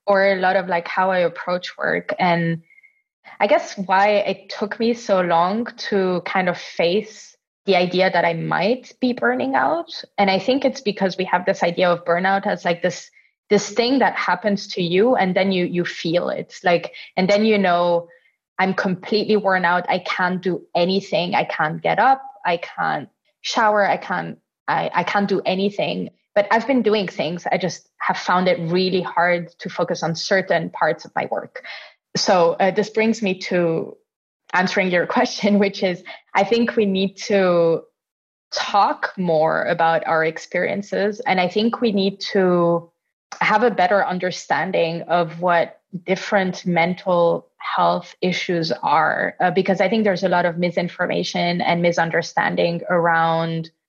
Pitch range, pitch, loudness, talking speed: 175-205 Hz, 185 Hz, -20 LUFS, 170 wpm